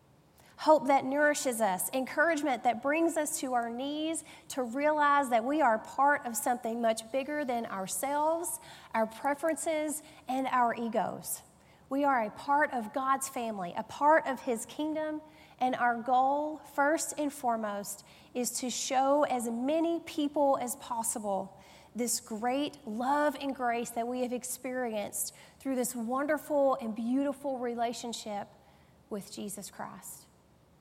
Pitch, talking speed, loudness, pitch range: 260 Hz, 140 wpm, -31 LUFS, 235-290 Hz